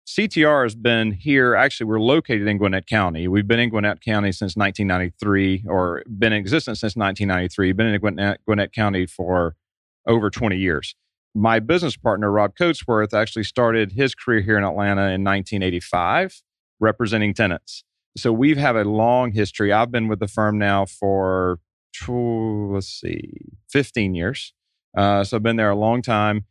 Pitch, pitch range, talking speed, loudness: 105 Hz, 100-115 Hz, 170 wpm, -20 LUFS